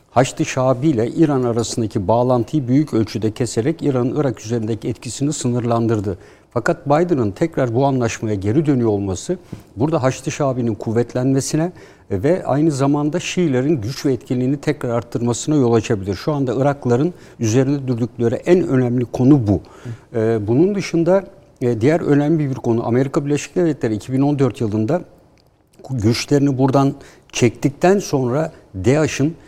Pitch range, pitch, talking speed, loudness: 115-150 Hz, 130 Hz, 125 wpm, -18 LUFS